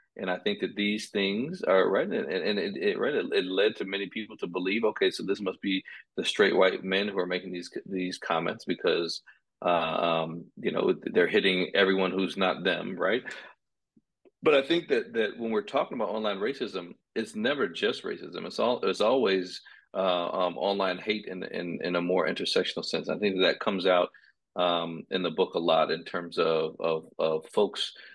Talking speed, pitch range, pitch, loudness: 200 wpm, 85-105 Hz, 95 Hz, -28 LUFS